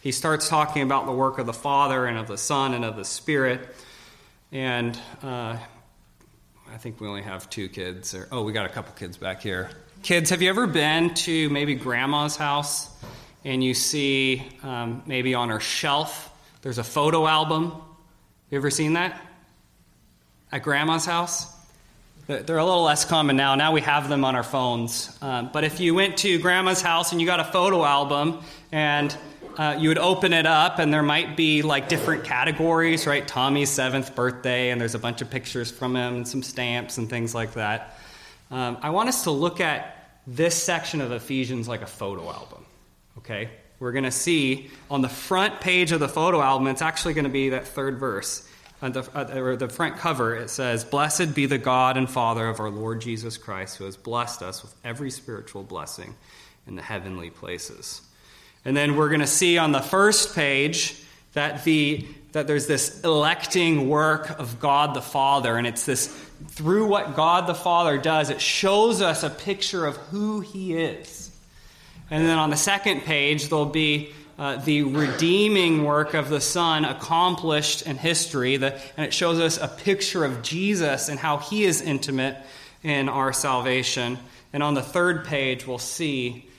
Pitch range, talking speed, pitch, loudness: 125-160 Hz, 190 wpm, 145 Hz, -23 LUFS